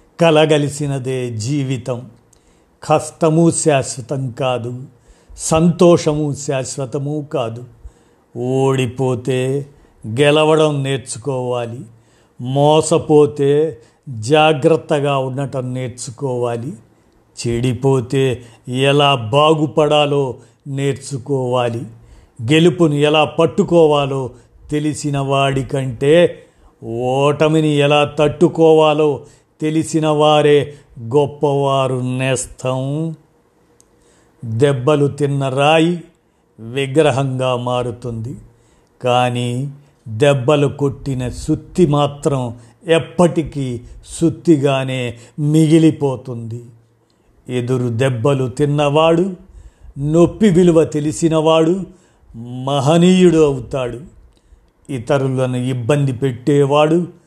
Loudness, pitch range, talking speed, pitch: -16 LUFS, 125-155 Hz, 60 wpm, 140 Hz